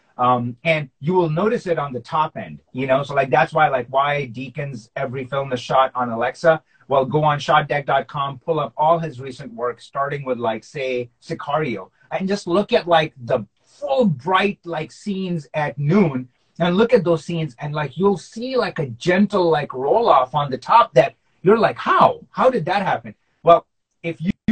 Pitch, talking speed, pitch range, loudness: 150 Hz, 200 wpm, 130-170 Hz, -20 LUFS